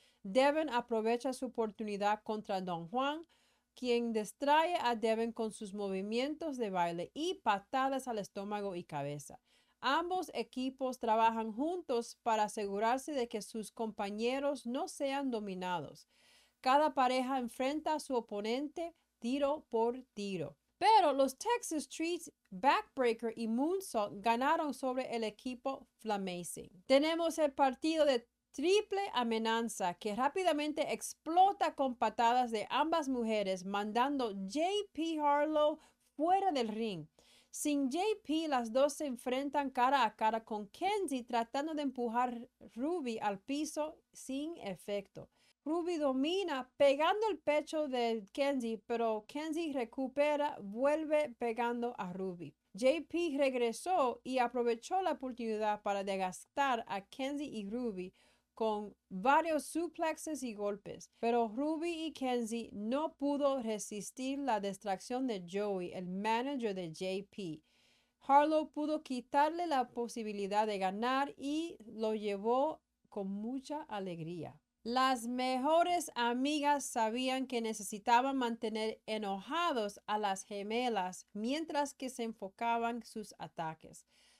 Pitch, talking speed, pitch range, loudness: 245 Hz, 120 wpm, 215-290 Hz, -35 LUFS